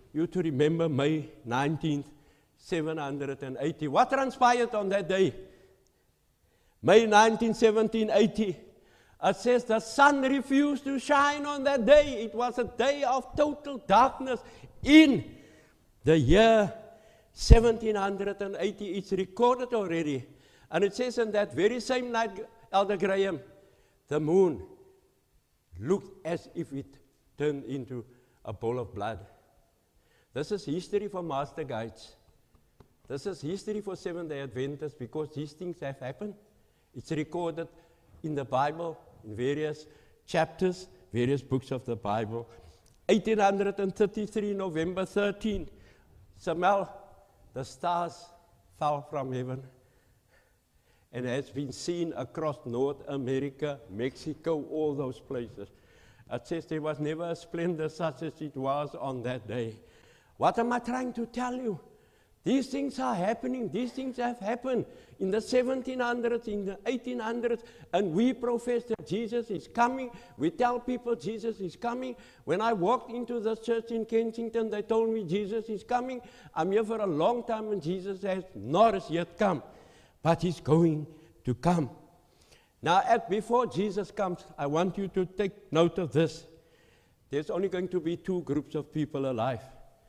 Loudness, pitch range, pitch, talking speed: -29 LUFS, 145-225 Hz, 180 Hz, 140 wpm